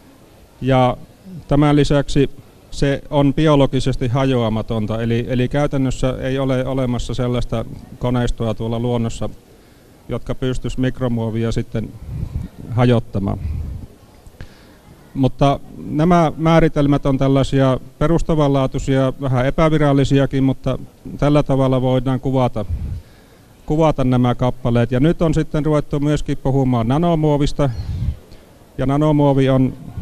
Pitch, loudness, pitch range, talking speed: 130 Hz, -18 LUFS, 120-145 Hz, 100 wpm